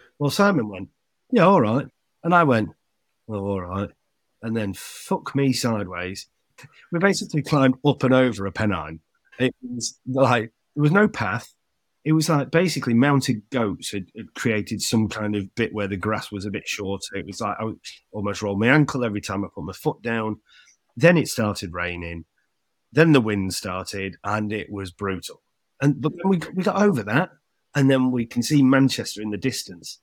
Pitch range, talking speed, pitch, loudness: 100-140 Hz, 190 wpm, 115 Hz, -22 LUFS